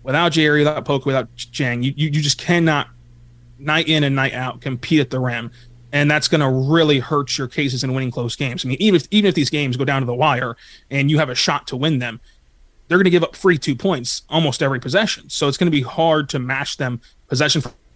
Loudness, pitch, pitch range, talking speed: -18 LUFS, 140 Hz, 125-155 Hz, 235 wpm